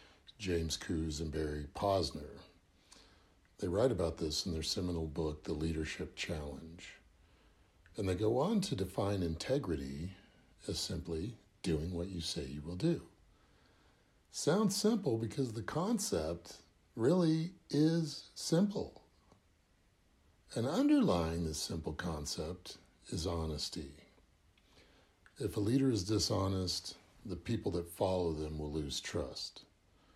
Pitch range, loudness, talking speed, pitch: 80-105 Hz, -36 LUFS, 120 wpm, 85 Hz